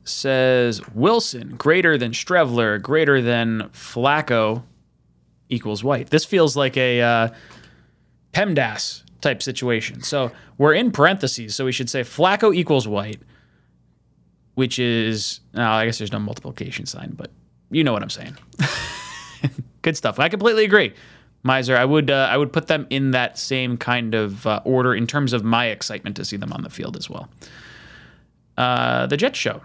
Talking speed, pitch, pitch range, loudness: 165 wpm, 125 Hz, 110-135 Hz, -20 LUFS